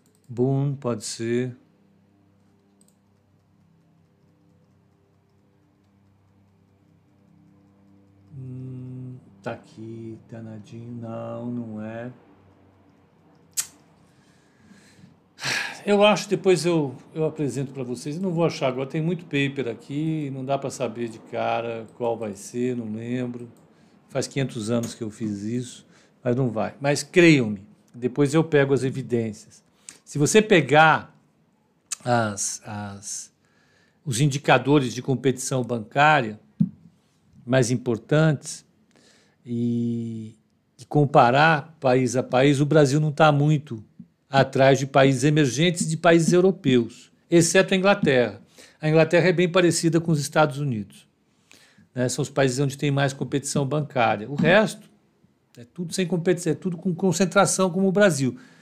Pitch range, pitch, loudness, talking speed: 115-155 Hz, 130 Hz, -22 LUFS, 125 wpm